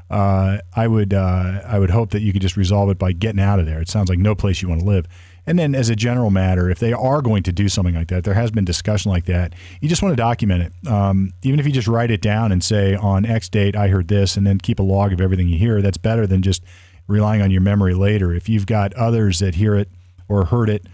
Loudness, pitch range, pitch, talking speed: -18 LUFS, 95-110 Hz, 100 Hz, 285 wpm